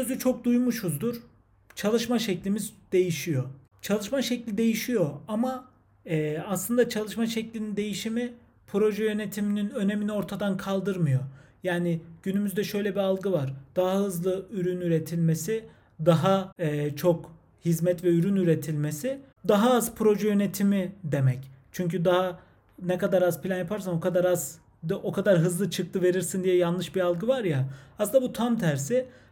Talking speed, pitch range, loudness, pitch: 140 wpm, 170-210 Hz, -27 LUFS, 190 Hz